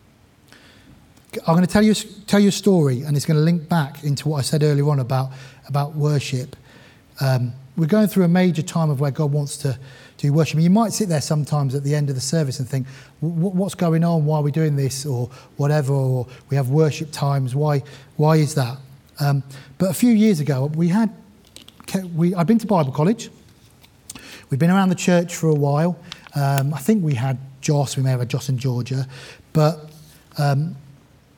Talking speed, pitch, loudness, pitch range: 210 wpm, 150 Hz, -20 LUFS, 135-170 Hz